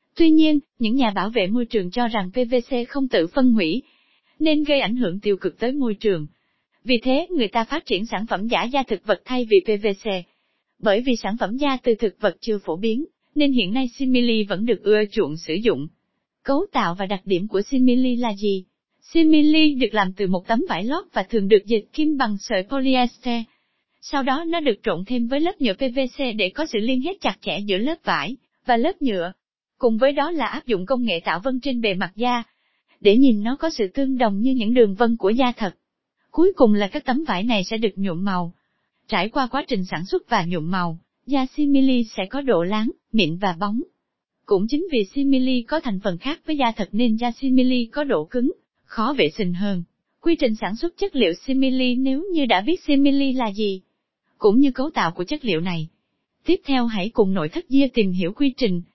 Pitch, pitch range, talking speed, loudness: 240 Hz, 205-275 Hz, 225 wpm, -21 LUFS